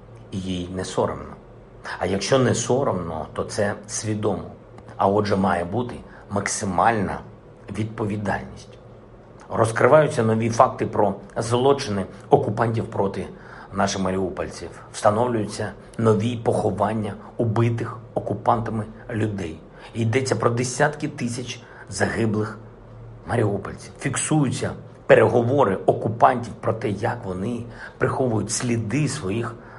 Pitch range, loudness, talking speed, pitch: 100-120 Hz, -23 LUFS, 95 wpm, 110 Hz